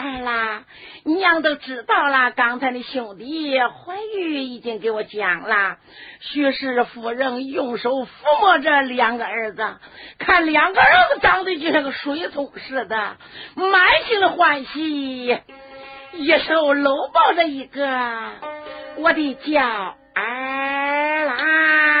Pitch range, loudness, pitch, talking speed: 250-310 Hz, -19 LUFS, 280 Hz, 175 characters per minute